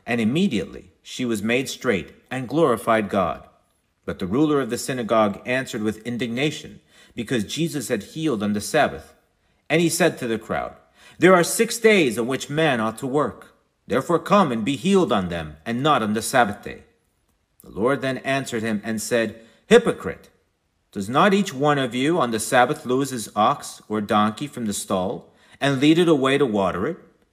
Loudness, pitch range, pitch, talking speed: -21 LUFS, 110-155 Hz, 125 Hz, 190 wpm